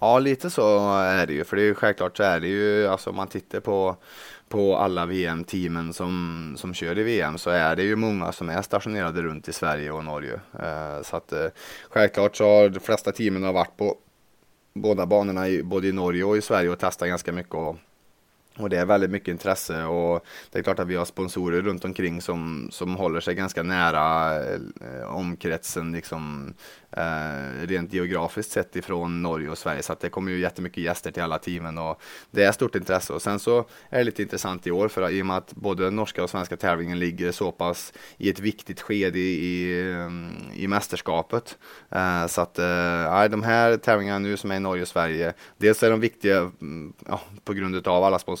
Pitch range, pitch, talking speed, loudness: 85-100 Hz, 90 Hz, 205 wpm, -25 LUFS